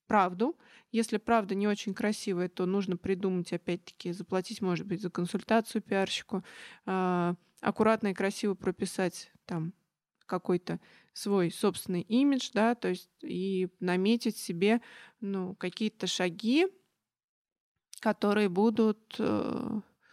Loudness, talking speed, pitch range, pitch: -31 LUFS, 105 wpm, 180-220 Hz, 195 Hz